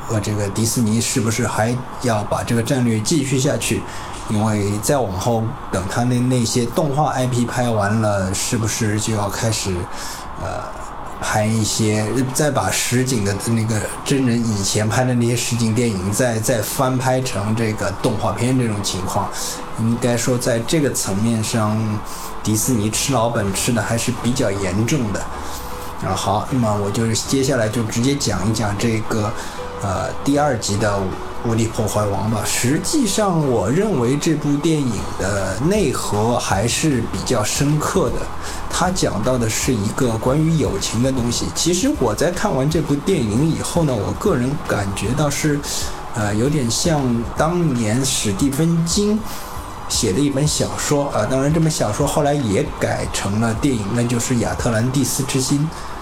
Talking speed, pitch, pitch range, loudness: 245 characters per minute, 115 Hz, 105-130 Hz, -19 LUFS